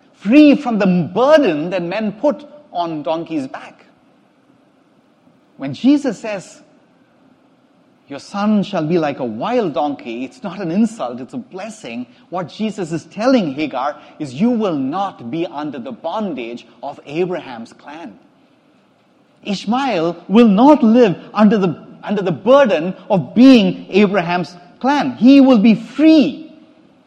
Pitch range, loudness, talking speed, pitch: 185-275 Hz, -15 LUFS, 135 wpm, 230 Hz